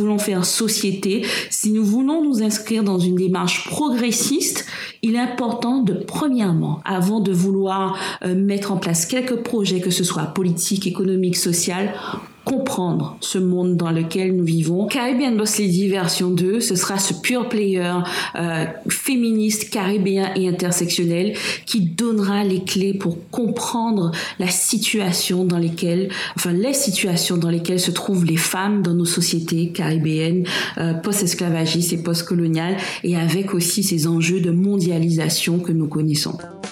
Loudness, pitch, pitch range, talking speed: -20 LUFS, 185 Hz, 175-210 Hz, 145 wpm